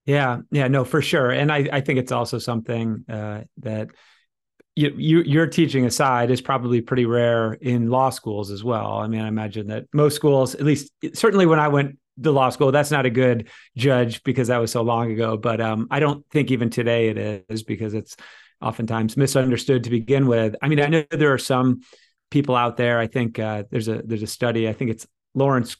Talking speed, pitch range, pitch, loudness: 215 wpm, 115-140 Hz, 125 Hz, -21 LUFS